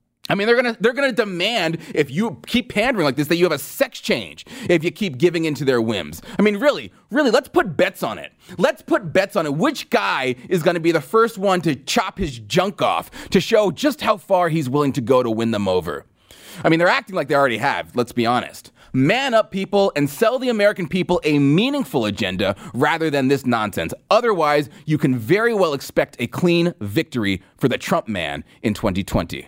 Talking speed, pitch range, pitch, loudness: 220 wpm, 130-205 Hz, 170 Hz, -19 LUFS